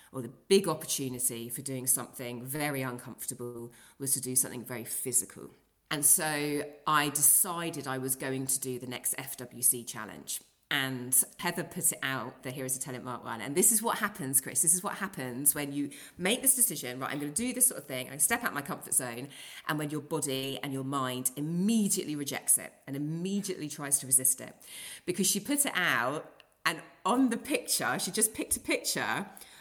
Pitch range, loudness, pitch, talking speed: 130-170 Hz, -29 LUFS, 140 Hz, 205 wpm